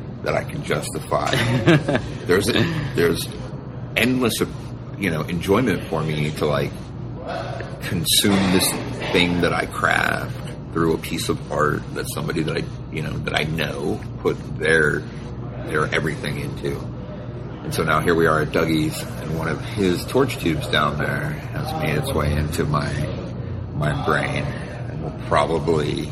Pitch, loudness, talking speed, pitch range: 90 Hz, -22 LUFS, 150 wpm, 80-120 Hz